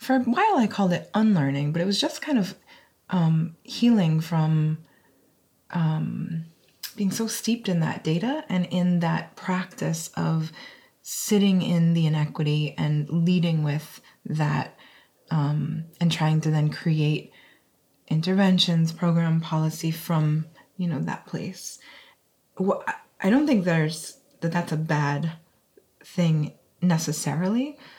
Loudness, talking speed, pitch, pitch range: -25 LUFS, 130 wpm, 165 Hz, 155-185 Hz